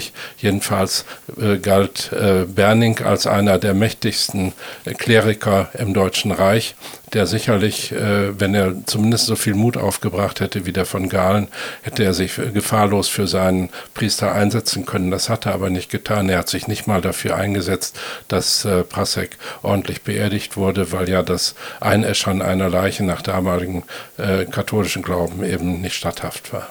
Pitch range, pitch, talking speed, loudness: 95-105 Hz, 100 Hz, 160 wpm, -19 LUFS